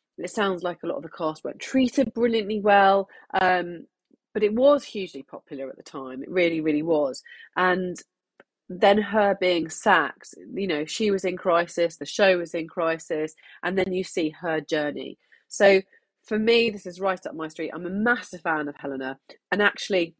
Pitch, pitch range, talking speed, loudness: 180 Hz, 160-205 Hz, 185 wpm, -24 LUFS